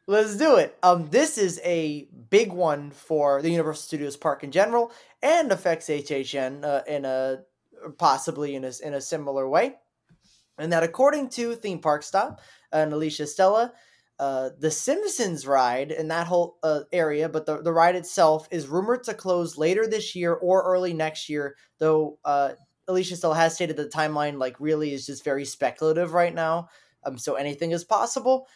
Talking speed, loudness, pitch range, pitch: 180 wpm, -25 LUFS, 145-180 Hz, 160 Hz